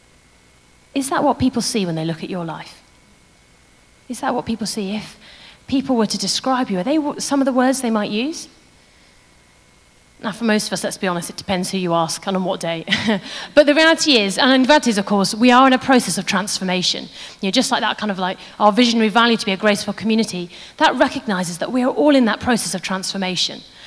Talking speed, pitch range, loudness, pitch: 230 wpm, 190-255 Hz, -18 LUFS, 215 Hz